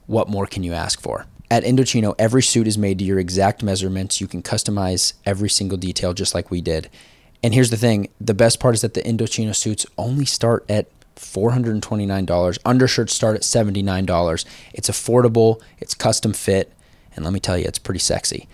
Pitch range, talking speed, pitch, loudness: 95-115 Hz, 190 wpm, 105 Hz, -19 LUFS